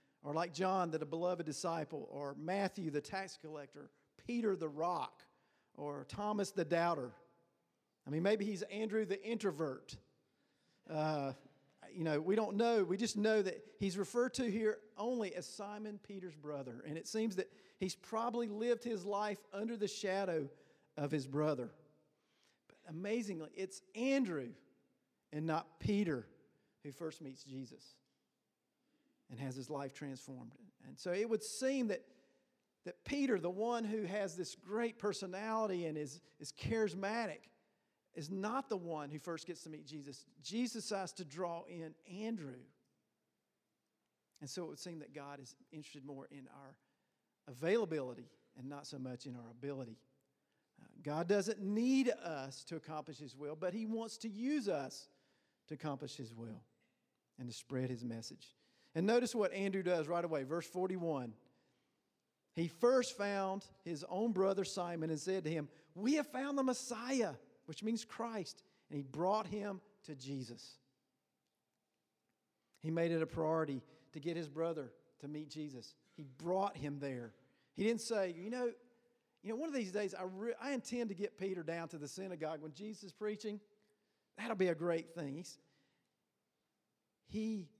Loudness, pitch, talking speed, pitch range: -41 LUFS, 175 Hz, 160 wpm, 150-210 Hz